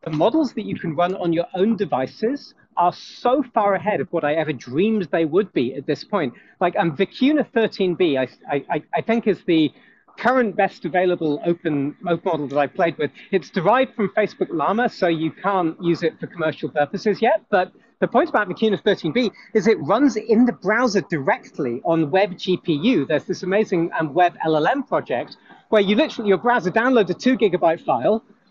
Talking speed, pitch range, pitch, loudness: 190 wpm, 165-220 Hz, 190 Hz, -21 LUFS